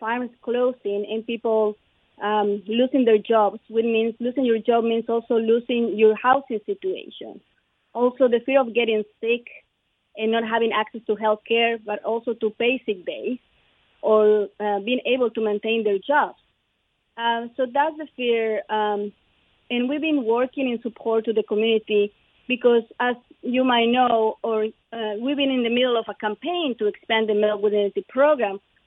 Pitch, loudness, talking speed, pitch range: 230 Hz, -22 LUFS, 170 wpm, 215-245 Hz